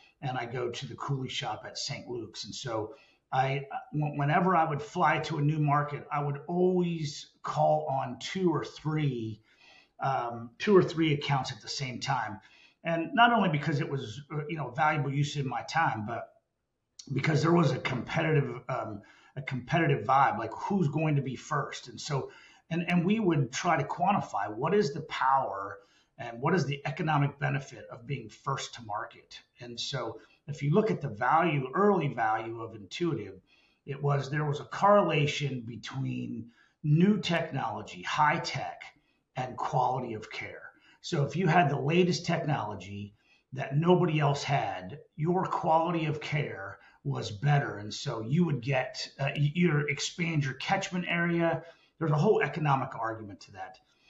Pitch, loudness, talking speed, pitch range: 150 Hz, -30 LUFS, 170 wpm, 135-165 Hz